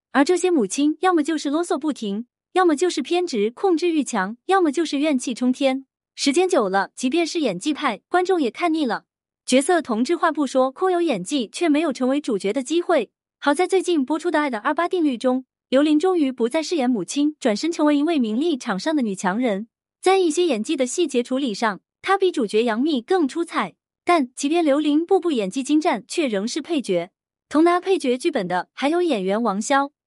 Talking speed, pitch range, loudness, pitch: 310 characters per minute, 250-340 Hz, -21 LUFS, 295 Hz